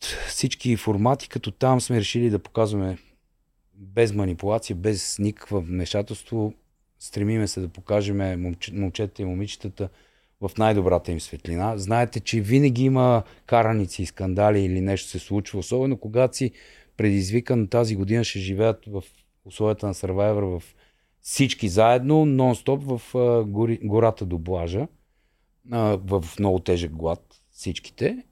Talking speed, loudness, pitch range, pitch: 130 wpm, -24 LUFS, 95-115 Hz, 105 Hz